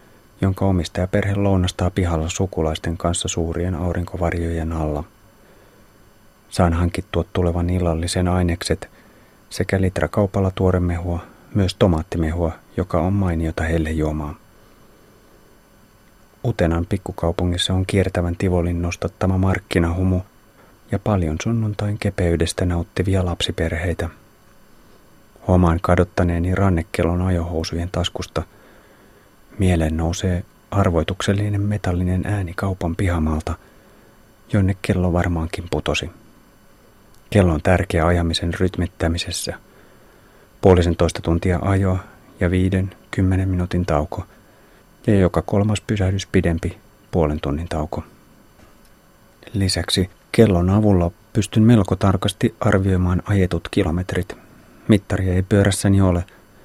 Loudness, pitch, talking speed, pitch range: -20 LUFS, 90 Hz, 95 wpm, 85-100 Hz